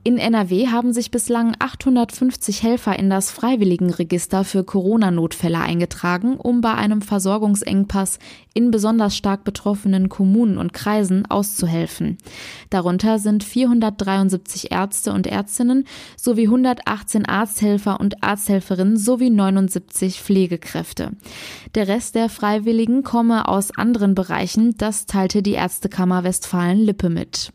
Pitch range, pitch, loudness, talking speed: 190-230 Hz, 205 Hz, -19 LUFS, 115 wpm